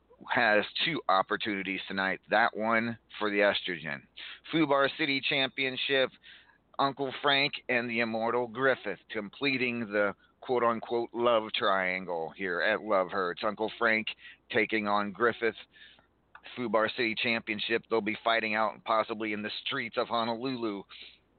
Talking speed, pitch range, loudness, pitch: 130 wpm, 105-125 Hz, -29 LUFS, 115 Hz